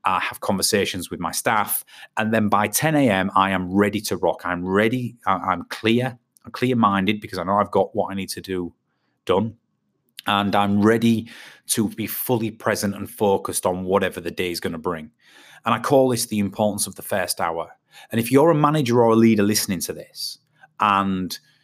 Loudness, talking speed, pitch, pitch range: -21 LUFS, 200 wpm, 105 Hz, 100-115 Hz